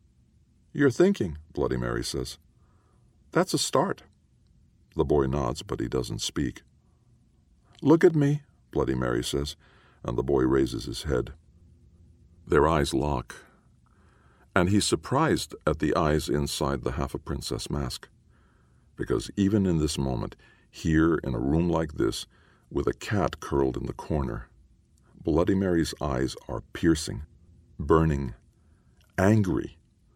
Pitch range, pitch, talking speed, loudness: 70-95 Hz, 80 Hz, 135 wpm, -27 LUFS